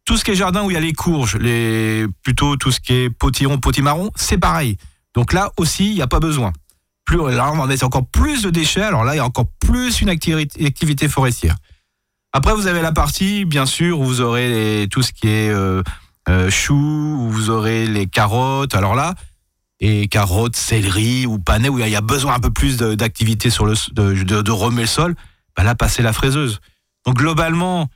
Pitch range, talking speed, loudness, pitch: 105-150 Hz, 220 wpm, -17 LUFS, 125 Hz